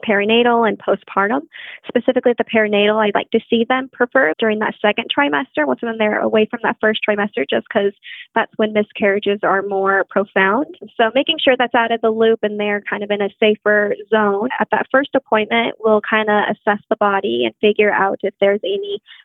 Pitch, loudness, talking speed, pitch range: 215 Hz, -17 LUFS, 200 wpm, 205-235 Hz